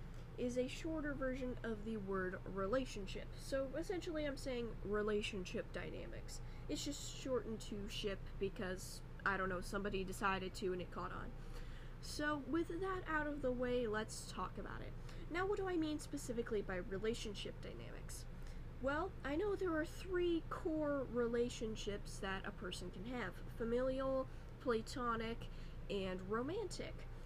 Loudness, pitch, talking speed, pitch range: -43 LUFS, 240 Hz, 145 wpm, 195-295 Hz